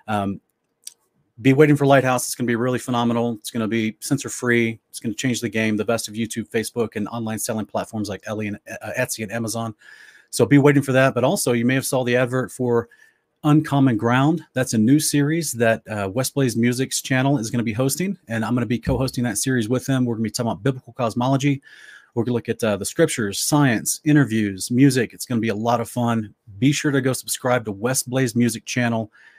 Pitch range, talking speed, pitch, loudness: 115-135 Hz, 240 wpm, 120 Hz, -21 LUFS